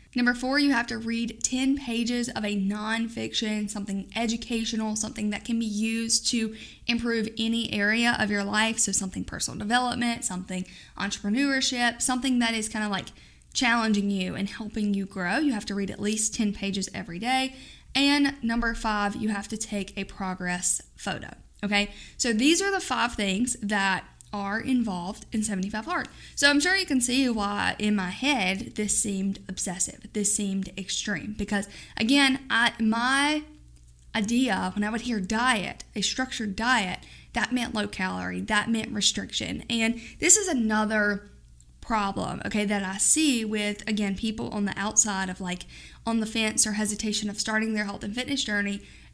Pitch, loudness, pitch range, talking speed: 215 Hz, -26 LUFS, 200-235 Hz, 170 wpm